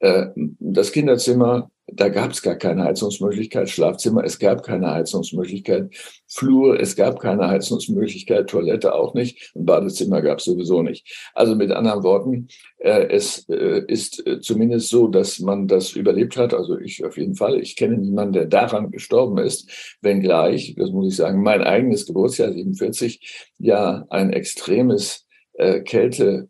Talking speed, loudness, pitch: 145 wpm, -19 LUFS, 125 Hz